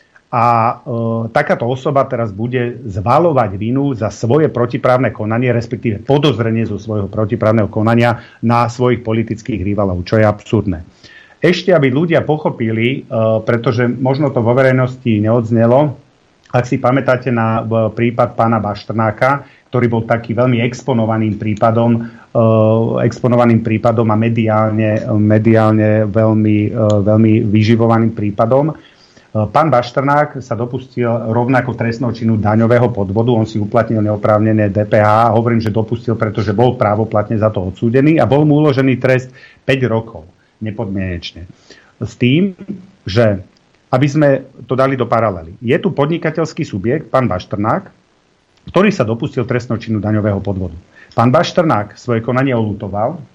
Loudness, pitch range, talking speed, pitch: -14 LUFS, 110-130 Hz, 135 wpm, 115 Hz